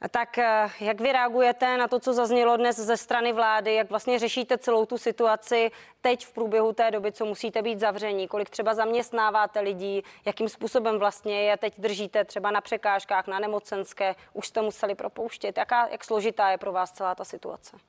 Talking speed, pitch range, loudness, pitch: 185 wpm, 205-235 Hz, -26 LUFS, 220 Hz